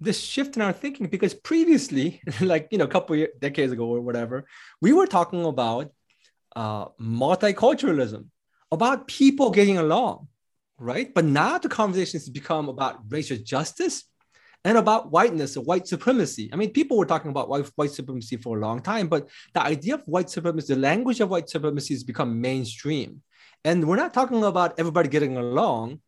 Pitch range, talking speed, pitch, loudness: 135-215 Hz, 180 wpm, 165 Hz, -24 LUFS